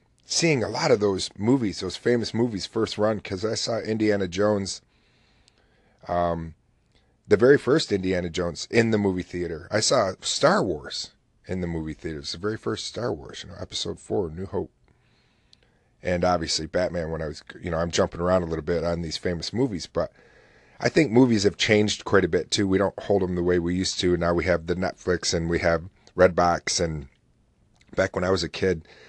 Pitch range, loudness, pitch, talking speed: 85-105 Hz, -24 LUFS, 90 Hz, 210 wpm